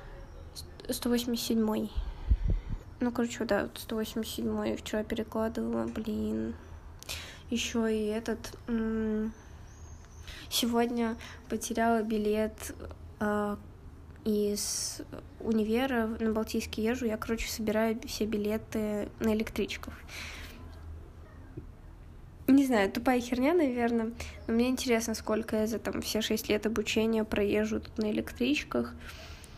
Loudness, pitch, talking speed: -31 LUFS, 215 Hz, 95 wpm